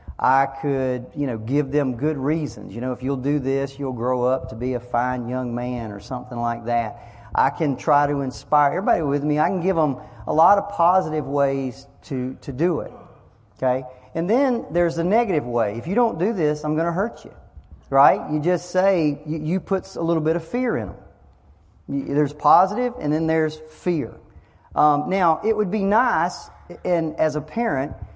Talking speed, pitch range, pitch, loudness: 200 wpm, 125-170 Hz, 145 Hz, -22 LUFS